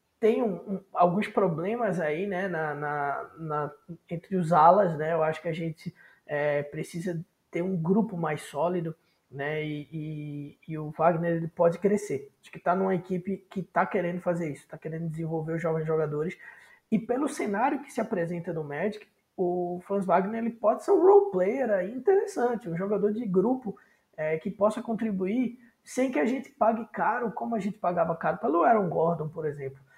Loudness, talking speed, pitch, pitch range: -28 LUFS, 185 wpm, 175 Hz, 160-210 Hz